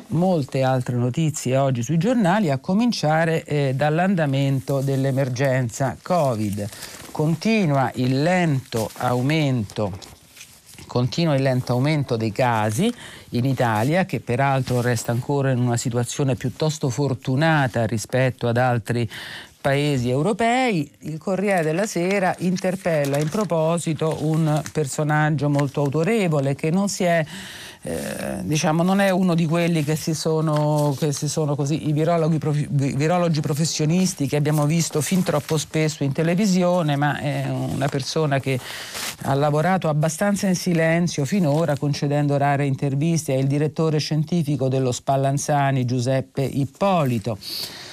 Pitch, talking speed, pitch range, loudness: 145 Hz, 130 wpm, 135-165 Hz, -21 LUFS